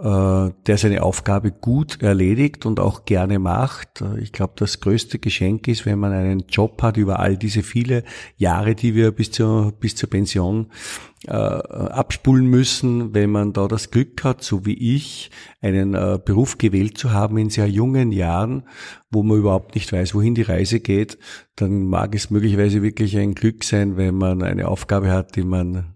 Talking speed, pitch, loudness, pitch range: 180 wpm, 105 Hz, -19 LUFS, 100-115 Hz